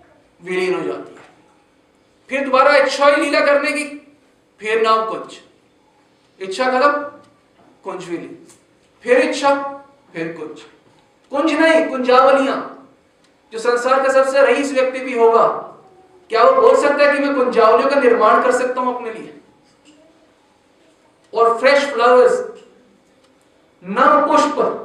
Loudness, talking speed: -15 LUFS, 120 wpm